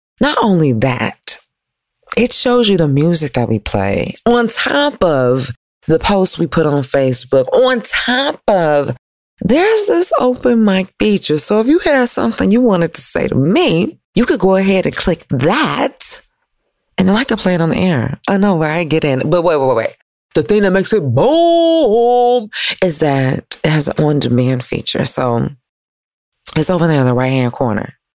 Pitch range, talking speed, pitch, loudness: 135-230 Hz, 190 wpm, 175 Hz, -13 LUFS